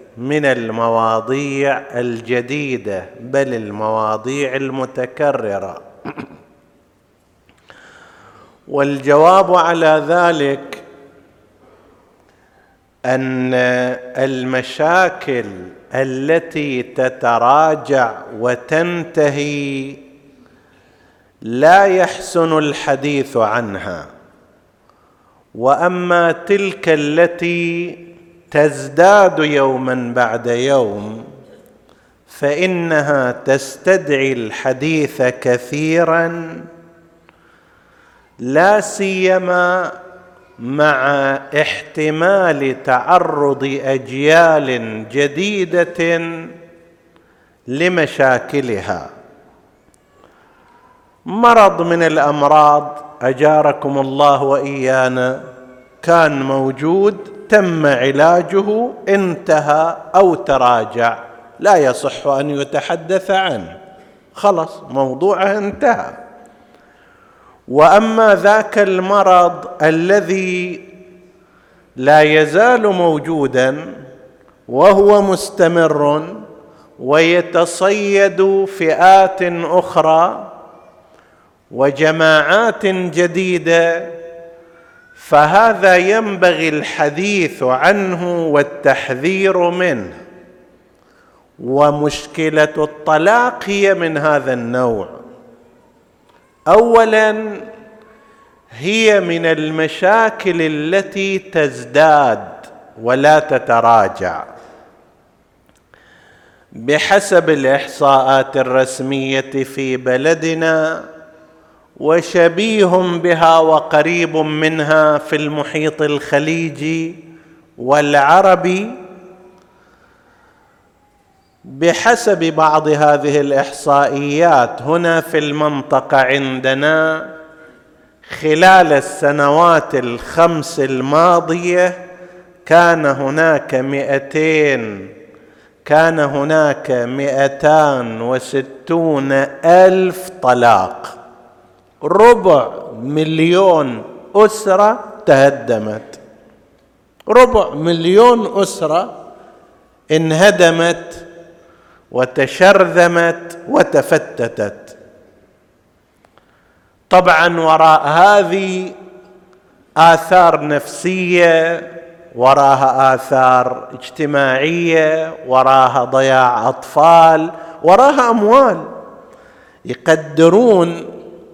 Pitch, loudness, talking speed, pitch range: 160 Hz, -13 LUFS, 50 wpm, 140-180 Hz